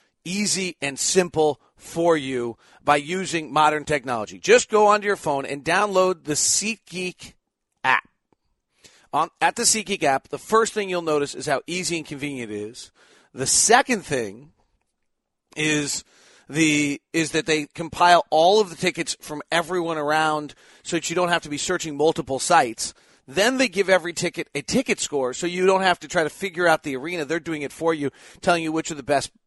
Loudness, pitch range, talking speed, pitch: -22 LUFS, 145-180 Hz, 185 wpm, 165 Hz